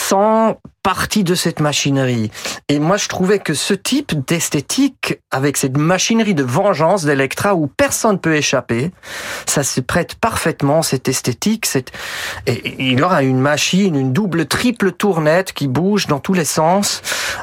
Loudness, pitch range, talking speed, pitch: -16 LUFS, 140-200 Hz, 155 wpm, 160 Hz